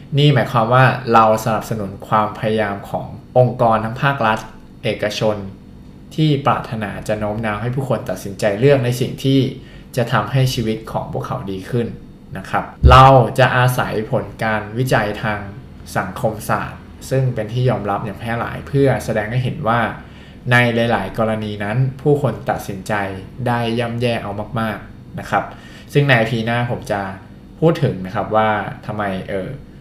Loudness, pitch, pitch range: -18 LUFS, 115 Hz, 105-130 Hz